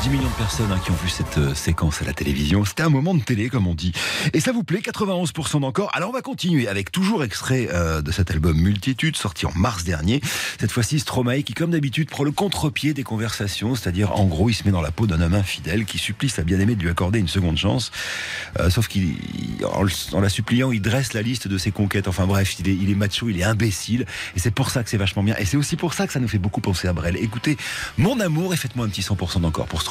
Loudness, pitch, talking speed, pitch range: -22 LUFS, 105 Hz, 265 wpm, 95-135 Hz